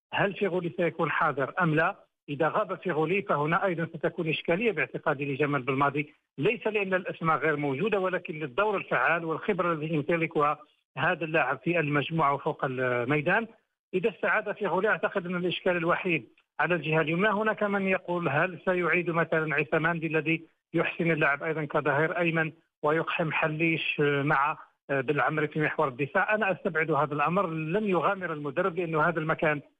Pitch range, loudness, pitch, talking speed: 155-185 Hz, -28 LUFS, 165 Hz, 145 wpm